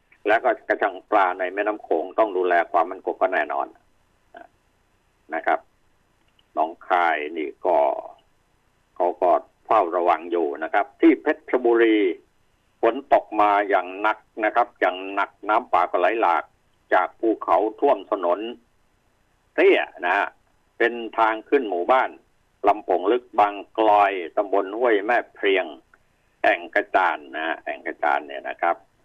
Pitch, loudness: 145 Hz, -22 LUFS